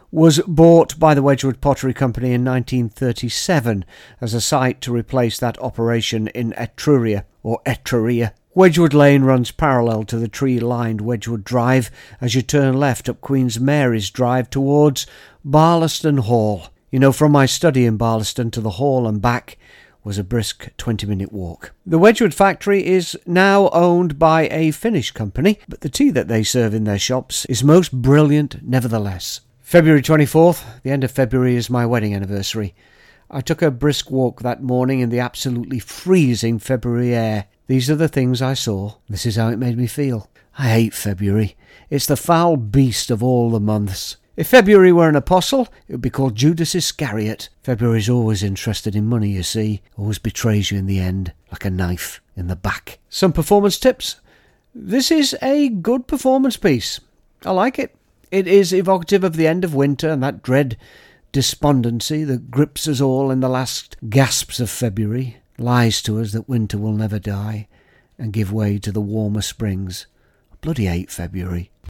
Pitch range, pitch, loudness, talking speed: 110-150 Hz, 125 Hz, -17 LUFS, 180 wpm